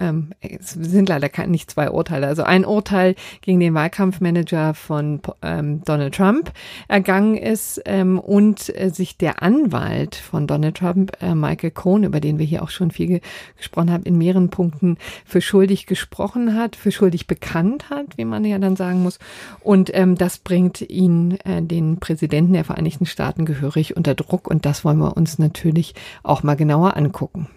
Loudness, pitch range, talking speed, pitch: -19 LUFS, 160-190 Hz, 160 wpm, 175 Hz